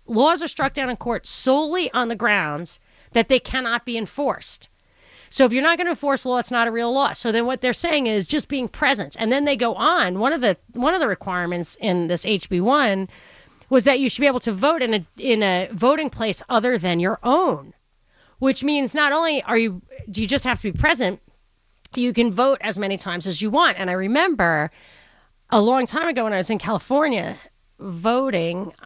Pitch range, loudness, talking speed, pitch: 210-275 Hz, -20 LUFS, 220 wpm, 240 Hz